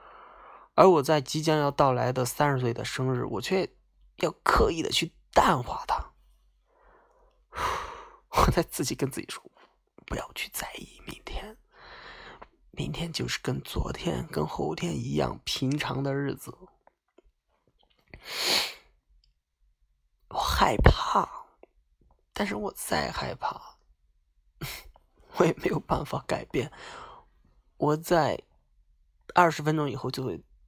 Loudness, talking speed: -28 LUFS, 165 characters per minute